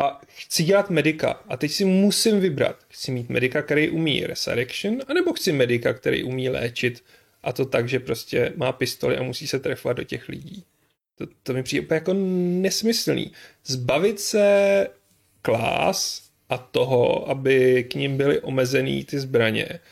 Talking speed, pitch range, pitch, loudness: 165 wpm, 130-190 Hz, 150 Hz, -22 LUFS